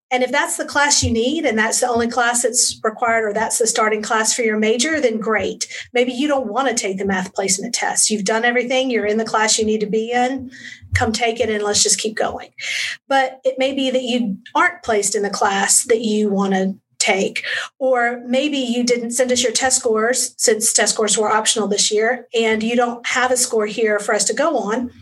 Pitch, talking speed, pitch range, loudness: 235 Hz, 235 wpm, 215-250 Hz, -17 LUFS